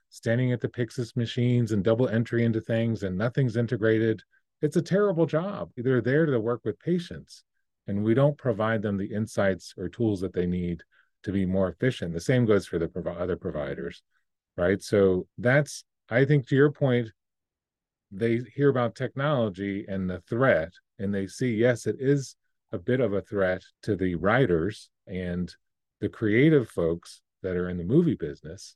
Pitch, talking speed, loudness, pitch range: 115 Hz, 180 wpm, -26 LUFS, 95-130 Hz